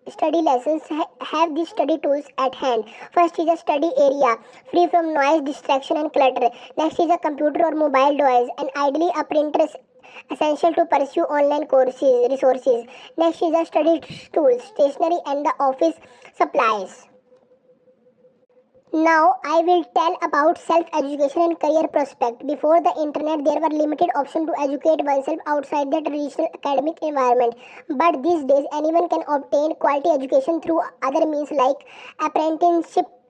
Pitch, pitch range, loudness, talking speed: 300 Hz, 275-330 Hz, -20 LUFS, 150 wpm